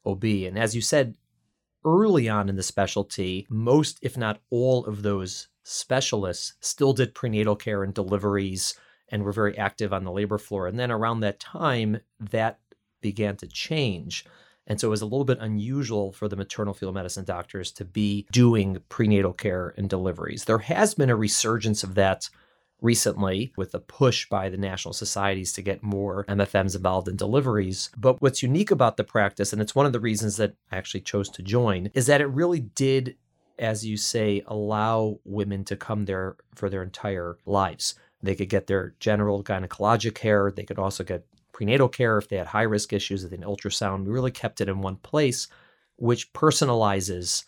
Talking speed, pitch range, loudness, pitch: 190 wpm, 100-115 Hz, -25 LUFS, 105 Hz